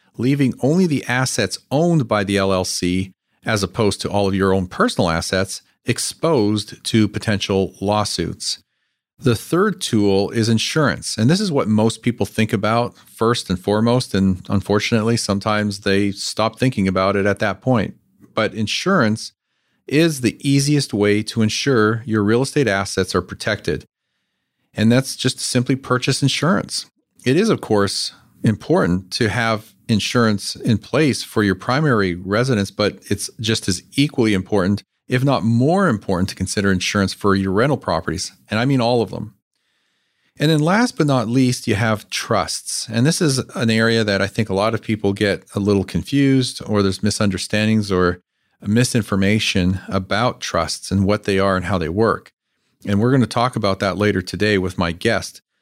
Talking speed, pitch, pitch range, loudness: 170 wpm, 105 Hz, 100-120 Hz, -19 LUFS